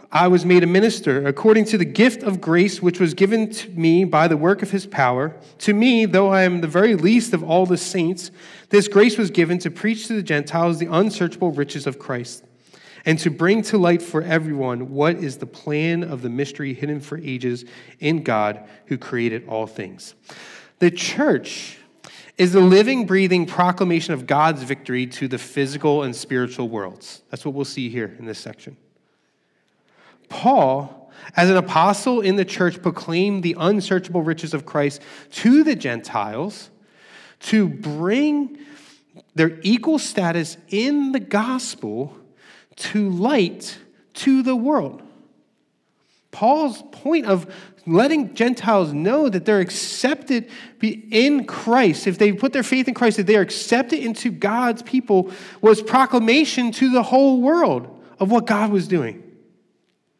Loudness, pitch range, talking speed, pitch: -19 LUFS, 155-220 Hz, 160 wpm, 185 Hz